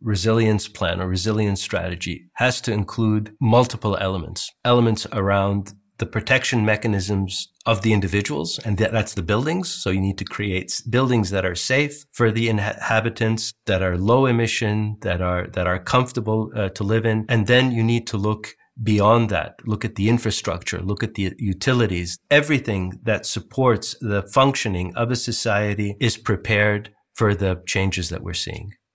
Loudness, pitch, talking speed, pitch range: -21 LUFS, 110 Hz, 165 wpm, 100-115 Hz